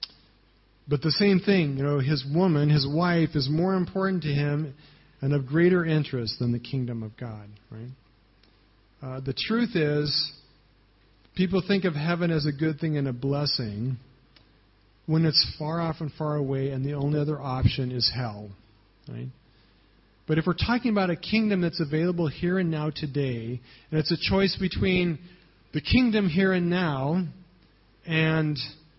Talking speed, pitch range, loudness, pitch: 165 wpm, 125-170 Hz, -26 LUFS, 150 Hz